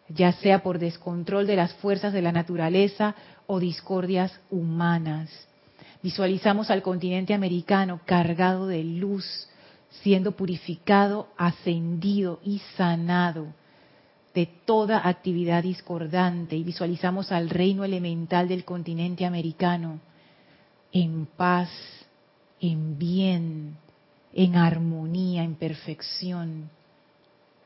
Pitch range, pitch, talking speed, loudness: 170-190 Hz, 180 Hz, 100 wpm, -26 LUFS